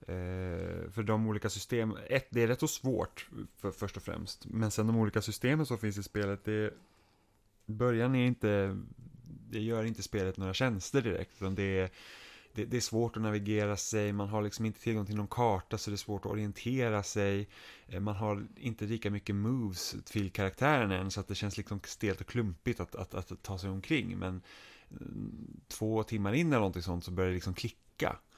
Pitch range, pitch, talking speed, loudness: 100-115 Hz, 105 Hz, 200 wpm, -34 LUFS